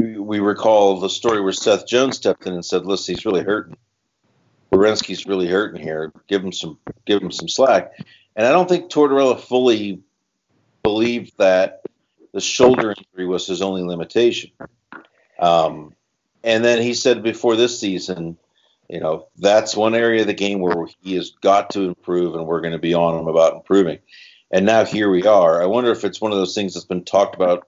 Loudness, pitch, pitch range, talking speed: -18 LUFS, 95 Hz, 90-110 Hz, 195 wpm